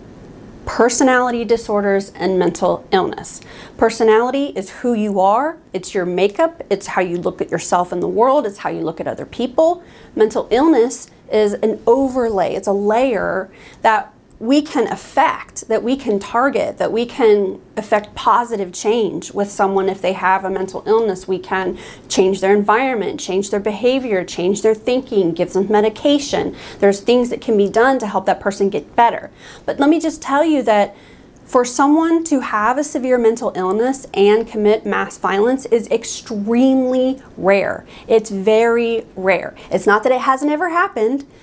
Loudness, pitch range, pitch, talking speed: -17 LUFS, 195-255 Hz, 220 Hz, 170 wpm